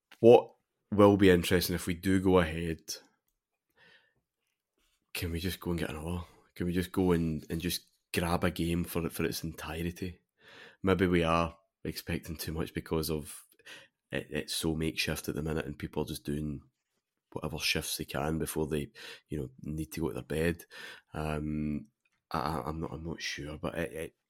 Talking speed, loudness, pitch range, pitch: 185 wpm, -32 LUFS, 75-85 Hz, 80 Hz